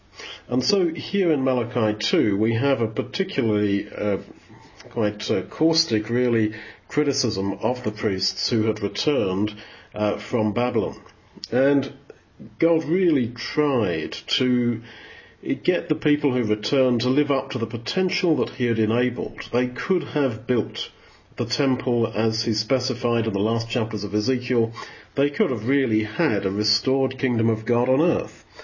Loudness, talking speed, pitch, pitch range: -23 LUFS, 150 wpm, 120 Hz, 110-135 Hz